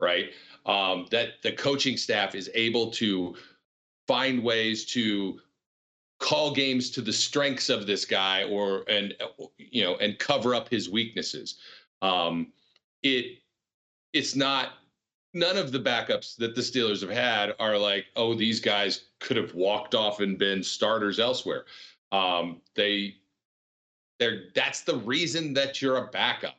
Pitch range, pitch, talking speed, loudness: 100-130 Hz, 110 Hz, 145 wpm, -27 LUFS